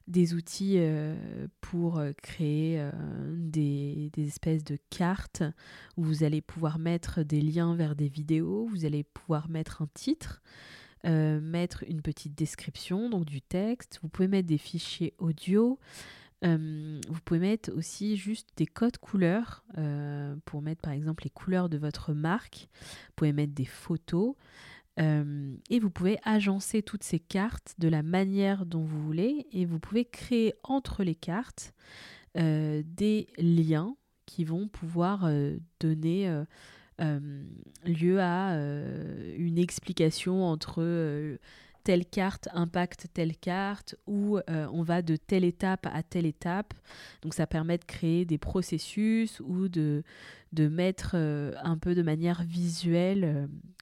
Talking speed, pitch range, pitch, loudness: 150 wpm, 155-185 Hz, 170 Hz, -31 LUFS